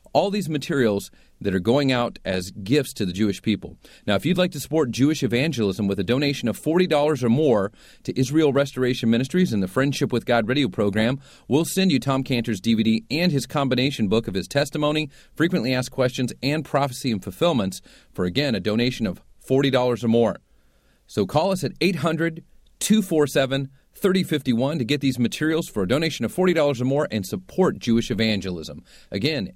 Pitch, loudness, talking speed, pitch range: 130 Hz, -22 LUFS, 185 wpm, 115-150 Hz